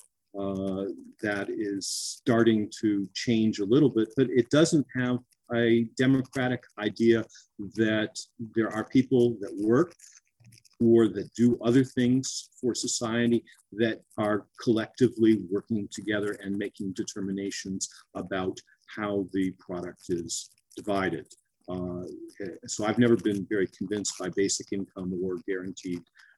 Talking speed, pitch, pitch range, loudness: 125 wpm, 110 Hz, 100-120 Hz, -28 LUFS